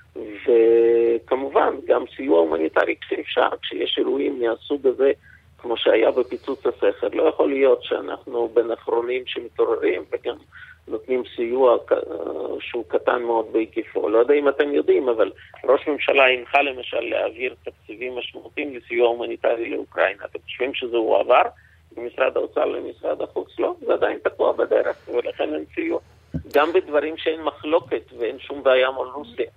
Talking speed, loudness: 140 wpm, -22 LUFS